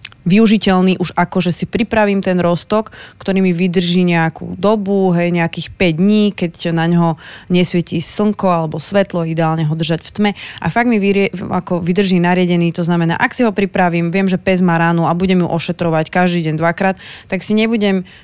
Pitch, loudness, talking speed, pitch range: 180 Hz, -14 LUFS, 190 wpm, 170-195 Hz